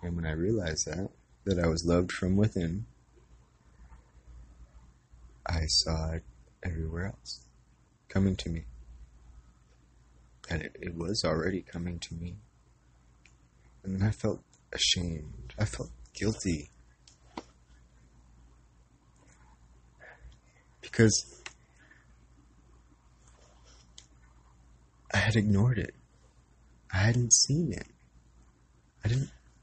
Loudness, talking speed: -30 LUFS, 95 wpm